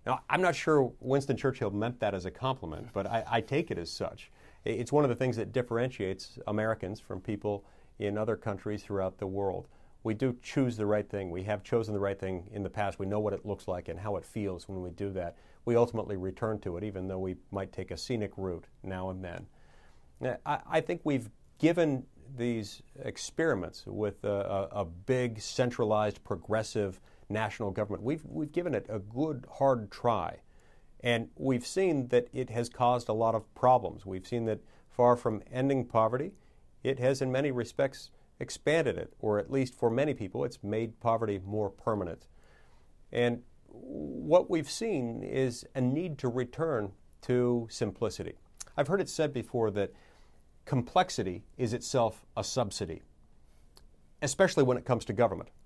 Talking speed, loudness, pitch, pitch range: 180 wpm, -32 LUFS, 110 Hz, 100-125 Hz